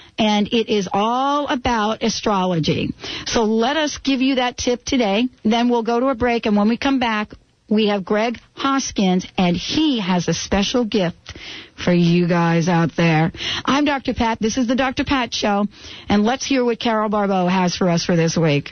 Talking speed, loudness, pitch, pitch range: 195 wpm, -19 LUFS, 220 Hz, 185-250 Hz